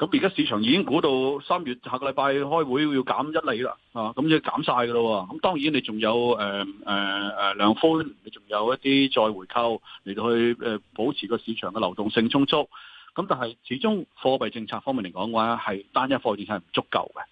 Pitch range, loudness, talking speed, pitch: 110-135 Hz, -25 LUFS, 310 characters per minute, 120 Hz